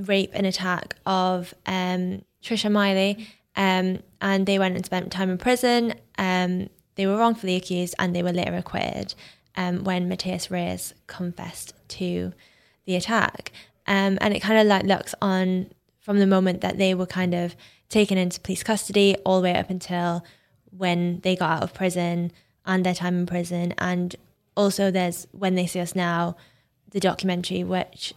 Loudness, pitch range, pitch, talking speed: -24 LUFS, 180-195 Hz, 185 Hz, 175 wpm